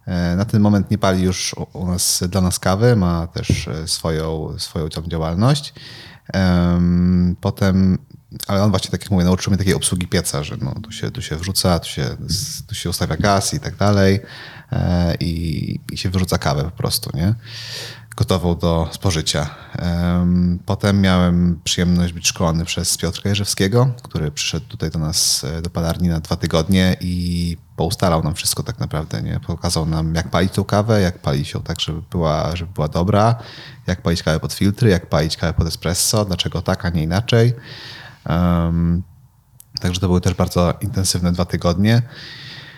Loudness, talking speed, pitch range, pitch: -19 LUFS, 170 wpm, 85-105 Hz, 90 Hz